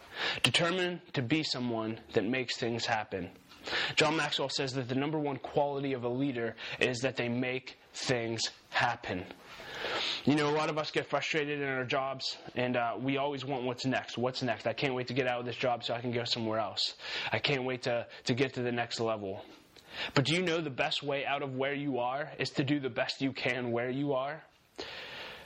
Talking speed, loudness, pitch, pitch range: 215 wpm, -32 LUFS, 130 Hz, 120-145 Hz